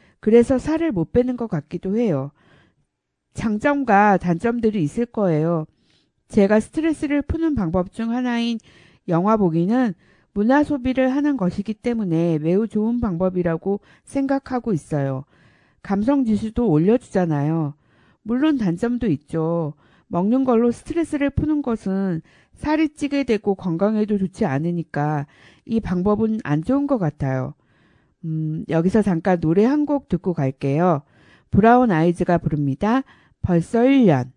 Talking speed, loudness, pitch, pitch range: 285 characters per minute, -21 LUFS, 200 Hz, 165-240 Hz